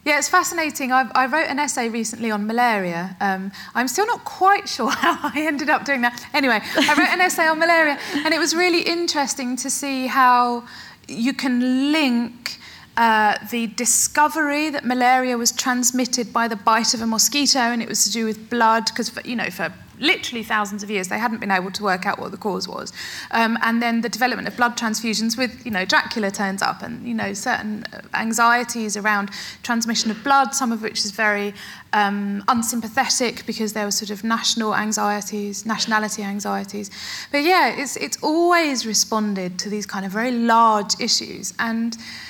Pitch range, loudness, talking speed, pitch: 215-270 Hz, -20 LUFS, 190 wpm, 235 Hz